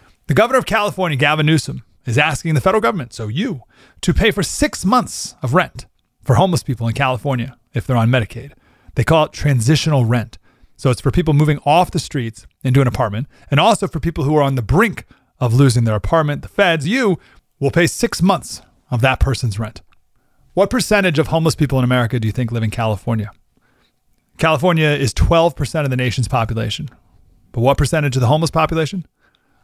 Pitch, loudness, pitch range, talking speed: 140 Hz, -17 LUFS, 120-160 Hz, 195 wpm